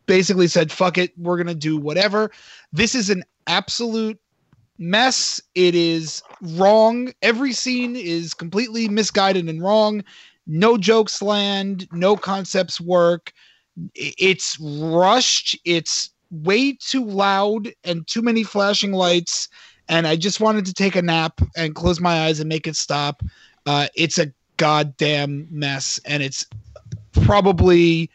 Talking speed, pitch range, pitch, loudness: 135 wpm, 160-205 Hz, 180 Hz, -19 LUFS